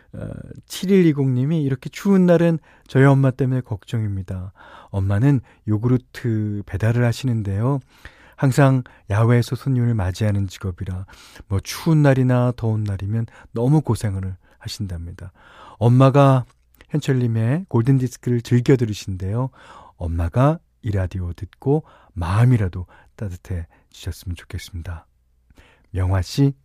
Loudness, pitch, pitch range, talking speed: -20 LUFS, 115 Hz, 95-135 Hz, 280 characters per minute